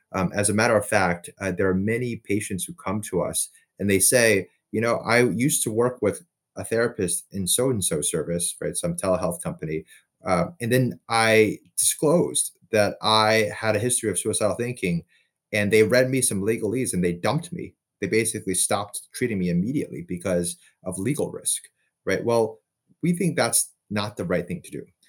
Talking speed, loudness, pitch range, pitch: 190 wpm, -23 LUFS, 95-125 Hz, 110 Hz